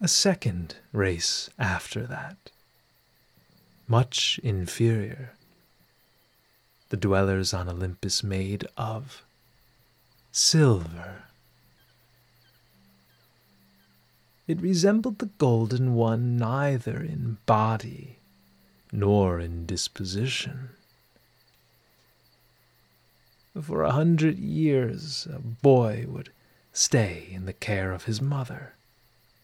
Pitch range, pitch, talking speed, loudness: 95-135 Hz, 115 Hz, 80 wpm, -26 LUFS